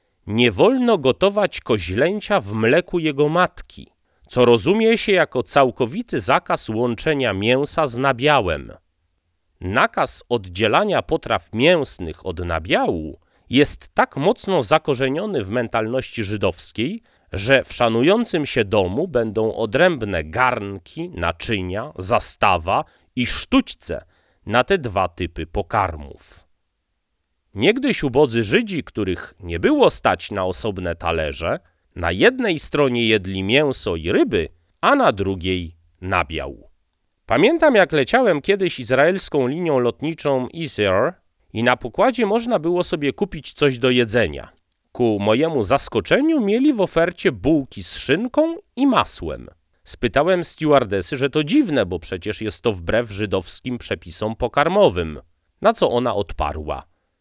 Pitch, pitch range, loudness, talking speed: 120 Hz, 95-155 Hz, -19 LUFS, 120 wpm